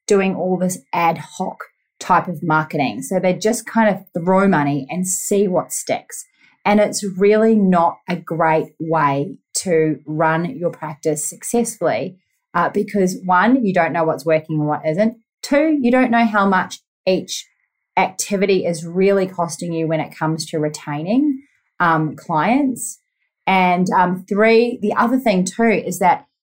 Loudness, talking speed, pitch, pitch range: -18 LUFS, 160 wpm, 185 Hz, 165-220 Hz